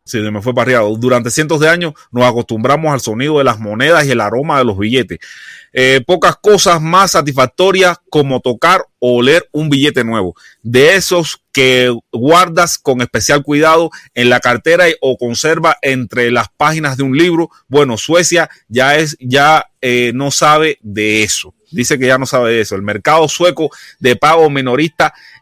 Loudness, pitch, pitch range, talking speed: -11 LUFS, 140 Hz, 125-160 Hz, 175 wpm